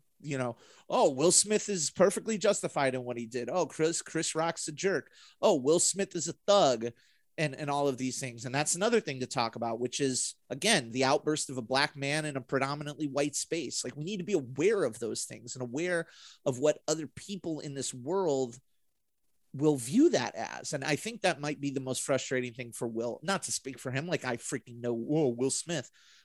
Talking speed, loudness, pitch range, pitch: 220 wpm, -31 LUFS, 125-170 Hz, 140 Hz